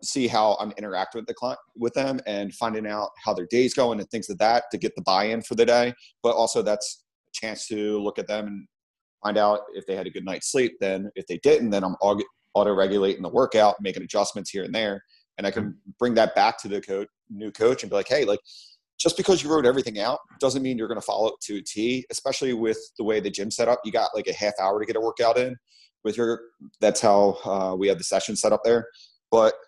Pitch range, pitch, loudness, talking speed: 105-130 Hz, 115 Hz, -24 LUFS, 250 wpm